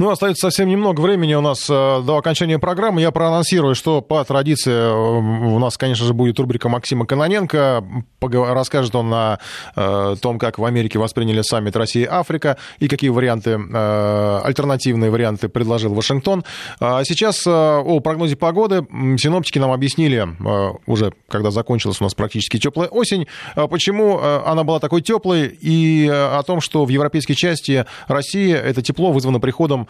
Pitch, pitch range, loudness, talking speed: 140 Hz, 115-160 Hz, -17 LUFS, 150 wpm